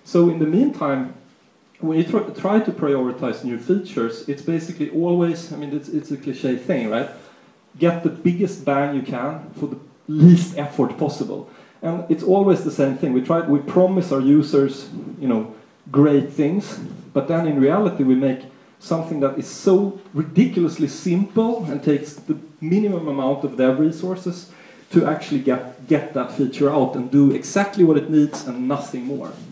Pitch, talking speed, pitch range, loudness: 155 Hz, 175 wpm, 140-180 Hz, -20 LUFS